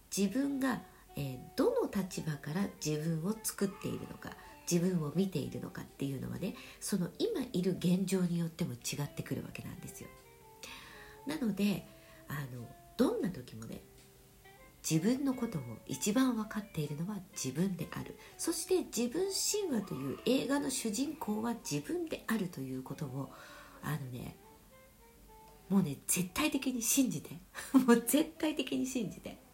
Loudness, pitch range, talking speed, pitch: -35 LUFS, 150-245 Hz, 290 characters per minute, 190 Hz